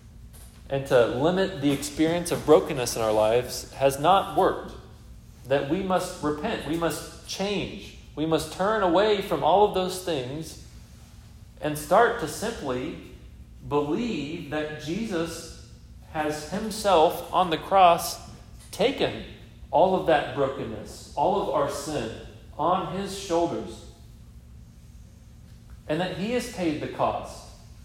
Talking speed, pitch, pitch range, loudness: 130 wpm, 155 Hz, 140-180 Hz, -25 LUFS